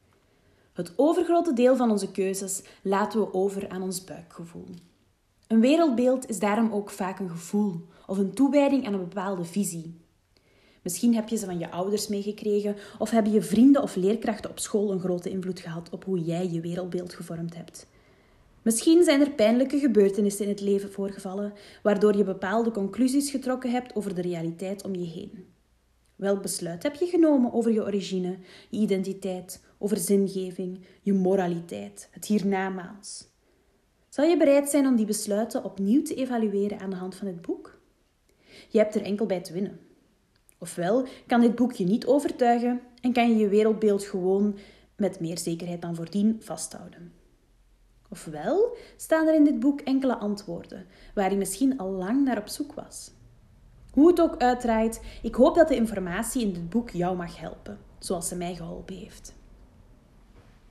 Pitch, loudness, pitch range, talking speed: 200 Hz, -26 LUFS, 180-235 Hz, 170 wpm